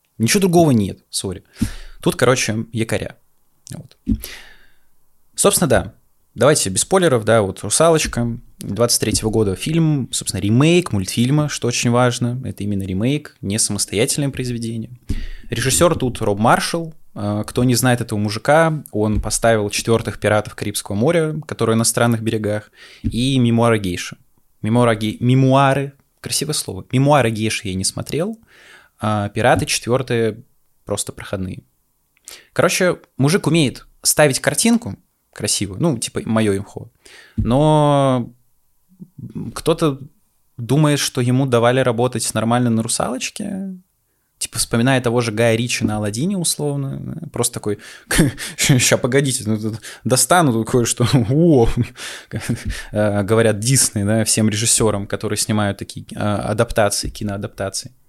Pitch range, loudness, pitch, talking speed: 110-140 Hz, -18 LUFS, 120 Hz, 120 wpm